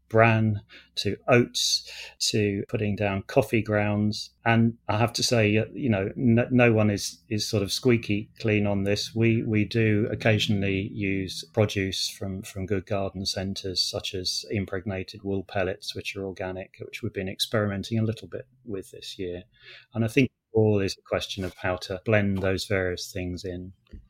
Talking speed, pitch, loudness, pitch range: 175 wpm, 105 Hz, -26 LUFS, 95-110 Hz